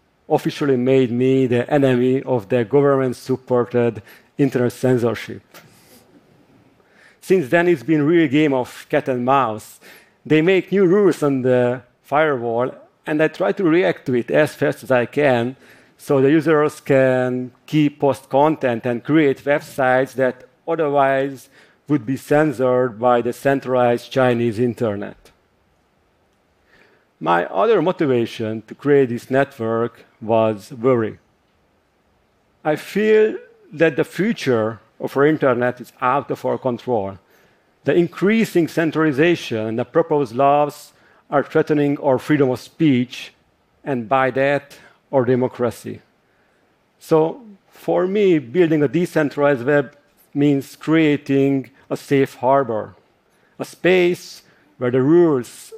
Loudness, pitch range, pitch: -18 LUFS, 125-155 Hz, 135 Hz